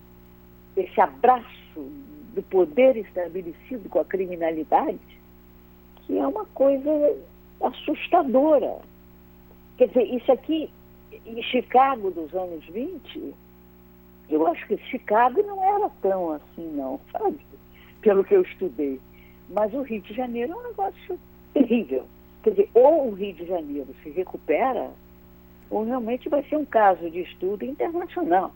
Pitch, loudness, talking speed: 190 Hz, -24 LUFS, 130 wpm